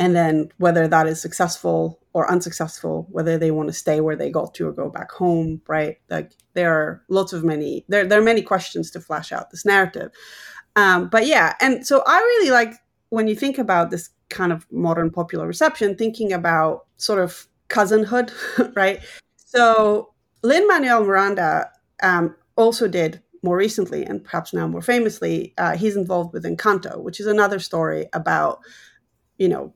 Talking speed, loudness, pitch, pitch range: 175 wpm, -20 LUFS, 185 Hz, 165-220 Hz